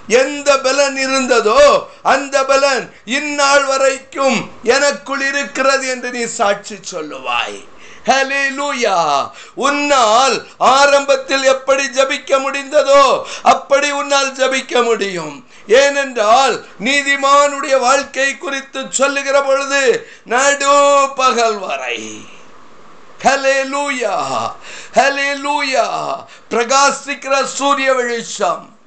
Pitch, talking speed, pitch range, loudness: 275 Hz, 60 wpm, 265-280 Hz, -14 LUFS